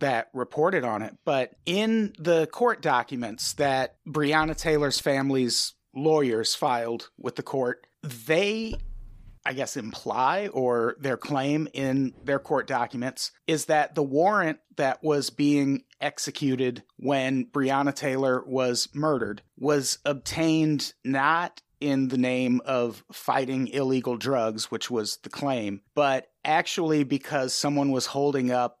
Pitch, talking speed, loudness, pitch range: 135 Hz, 130 wpm, -26 LUFS, 125-150 Hz